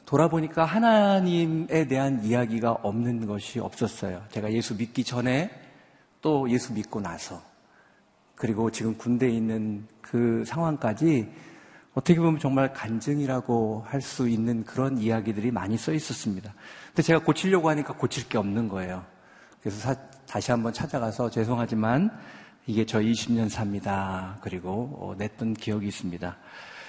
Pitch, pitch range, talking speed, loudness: 115 Hz, 110-135 Hz, 310 characters per minute, -27 LUFS